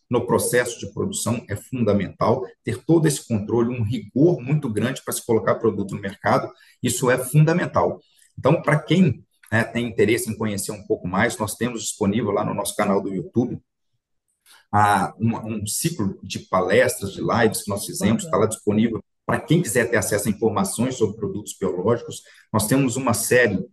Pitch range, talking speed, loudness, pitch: 110-130 Hz, 175 wpm, -22 LUFS, 115 Hz